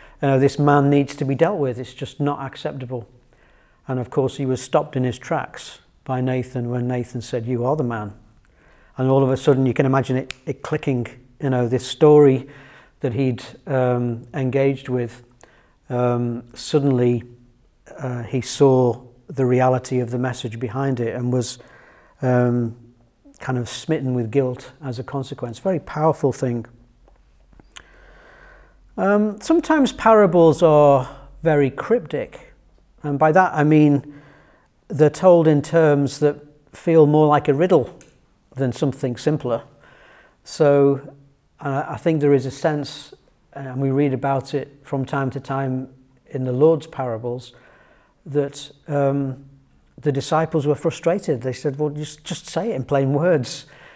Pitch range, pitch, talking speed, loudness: 125-150 Hz, 135 Hz, 155 wpm, -20 LUFS